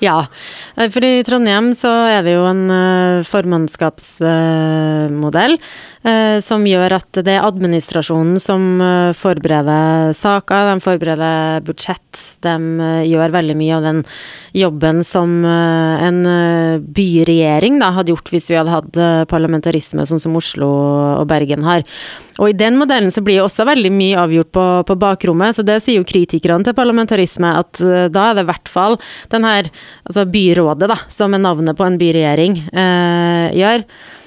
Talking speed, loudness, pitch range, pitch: 145 wpm, -13 LUFS, 160-195 Hz, 175 Hz